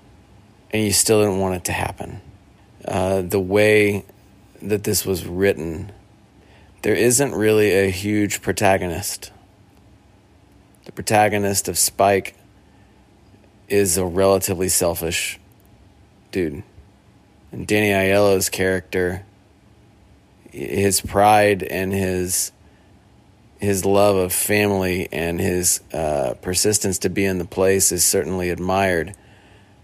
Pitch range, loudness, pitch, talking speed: 95-100 Hz, -19 LUFS, 100 Hz, 110 wpm